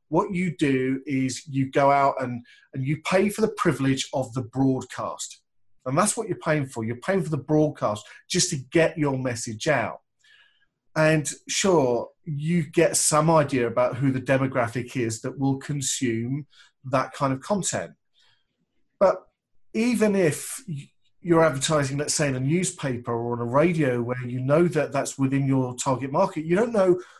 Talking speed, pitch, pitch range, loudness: 170 wpm, 140 Hz, 130-165 Hz, -24 LUFS